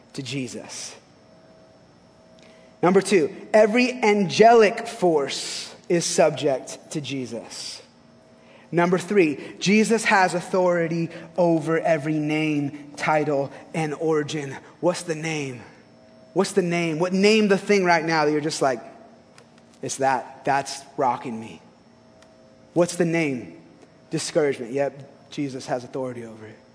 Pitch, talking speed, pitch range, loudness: 155 Hz, 120 wpm, 135-180 Hz, -22 LUFS